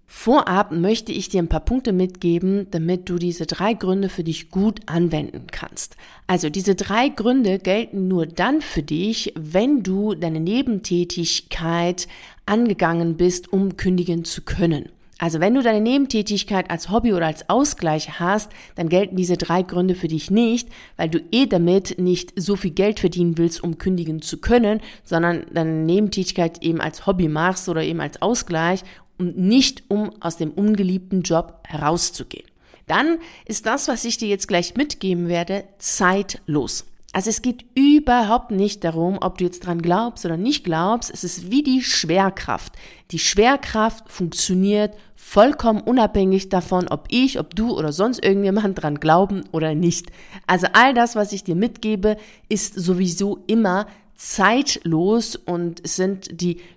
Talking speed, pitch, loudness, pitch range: 160 wpm, 185 Hz, -20 LUFS, 170-215 Hz